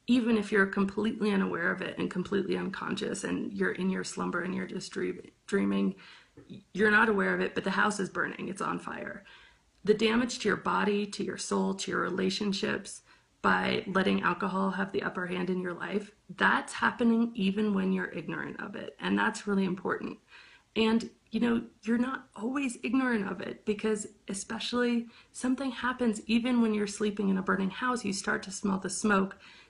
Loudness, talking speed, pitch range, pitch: -30 LUFS, 190 wpm, 190-225 Hz, 205 Hz